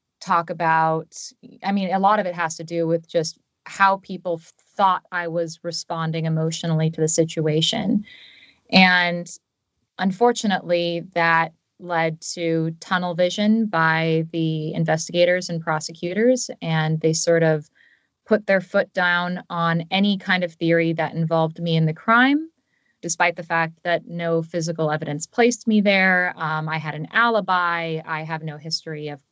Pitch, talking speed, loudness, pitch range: 170 Hz, 150 wpm, -21 LUFS, 160-185 Hz